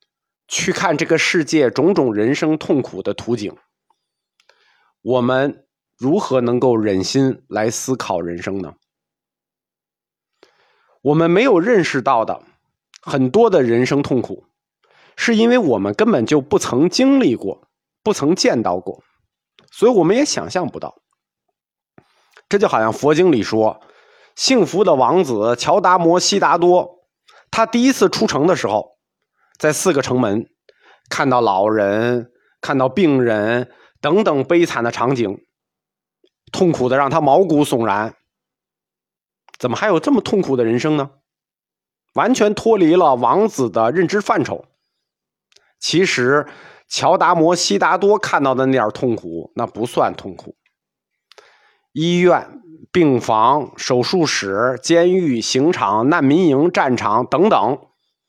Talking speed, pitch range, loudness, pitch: 195 characters per minute, 120-180 Hz, -16 LUFS, 140 Hz